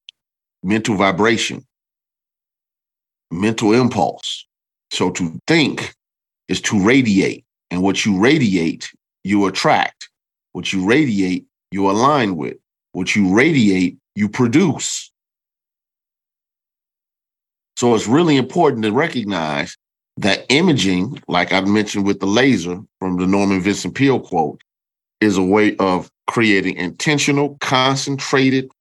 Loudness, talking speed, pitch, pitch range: -17 LUFS, 110 wpm, 100 Hz, 95-115 Hz